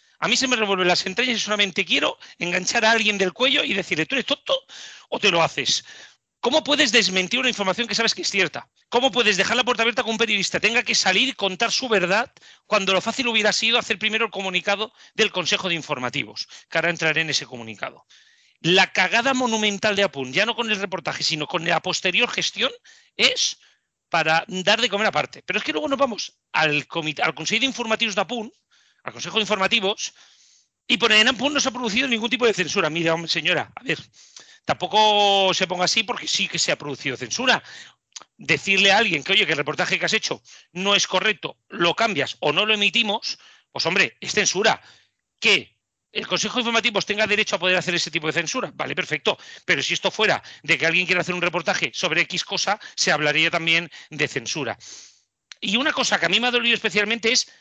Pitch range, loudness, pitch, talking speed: 175-230 Hz, -20 LUFS, 200 Hz, 210 wpm